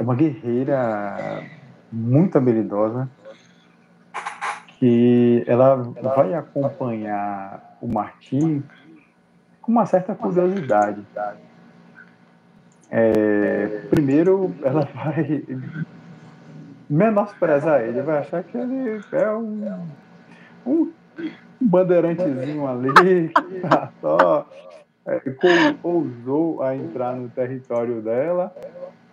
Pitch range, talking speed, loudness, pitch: 120-185 Hz, 85 wpm, -20 LUFS, 140 Hz